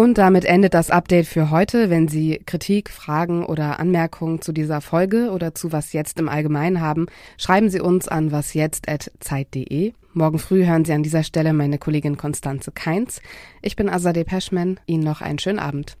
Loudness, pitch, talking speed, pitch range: -20 LUFS, 165 Hz, 185 wpm, 150-185 Hz